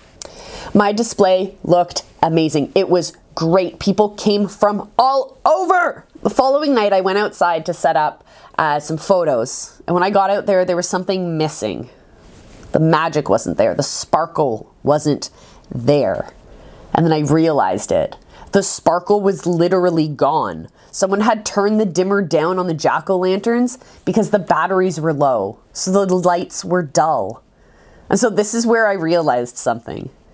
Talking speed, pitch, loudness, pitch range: 160 wpm, 185 Hz, -17 LUFS, 165-205 Hz